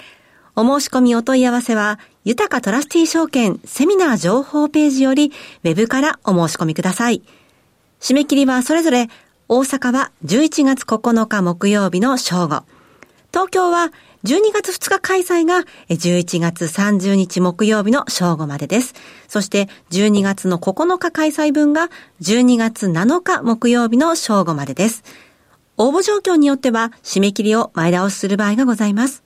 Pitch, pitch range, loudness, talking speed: 235 Hz, 200-290 Hz, -16 LUFS, 280 characters per minute